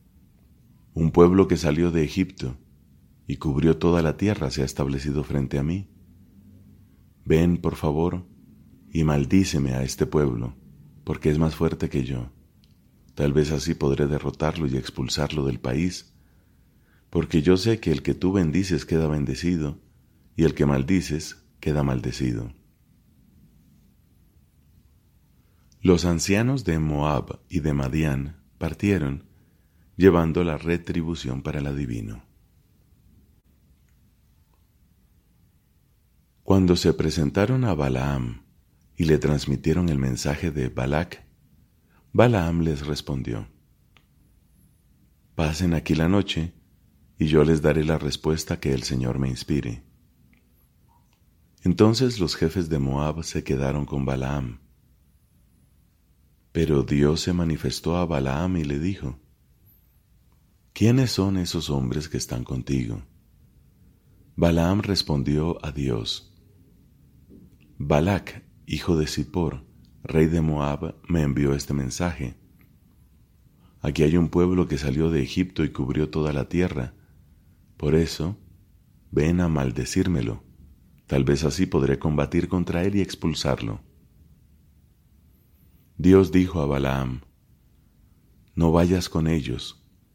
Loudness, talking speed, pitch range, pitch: -24 LUFS, 115 wpm, 70-90 Hz, 80 Hz